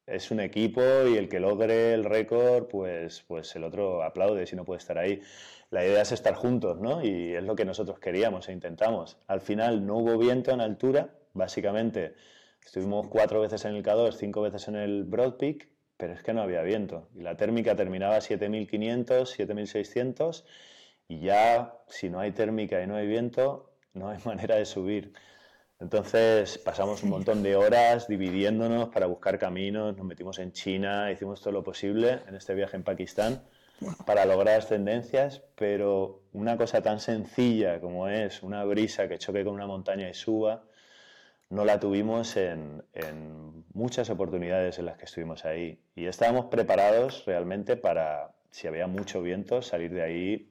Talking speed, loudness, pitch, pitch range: 175 wpm, -28 LUFS, 105 Hz, 95-115 Hz